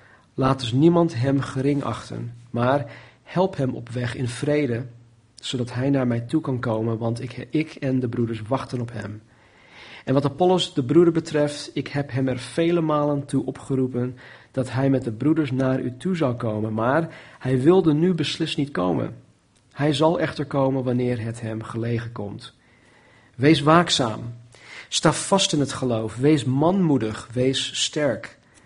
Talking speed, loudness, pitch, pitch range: 170 wpm, -23 LUFS, 130 Hz, 120-150 Hz